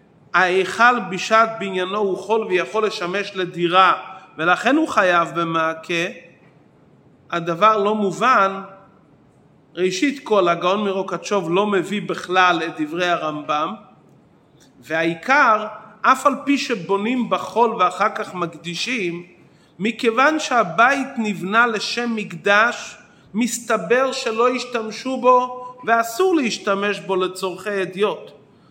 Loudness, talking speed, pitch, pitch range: -19 LUFS, 100 wpm, 200 Hz, 180-230 Hz